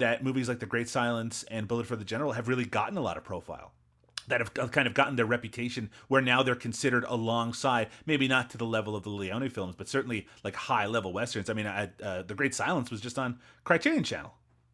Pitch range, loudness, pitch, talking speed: 110-125 Hz, -30 LUFS, 120 Hz, 230 wpm